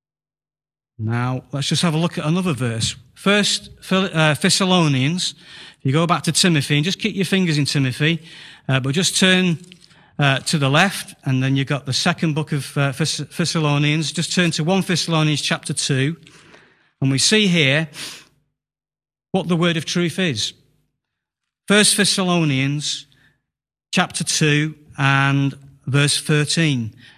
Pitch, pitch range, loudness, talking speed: 155 Hz, 140-175 Hz, -18 LUFS, 150 wpm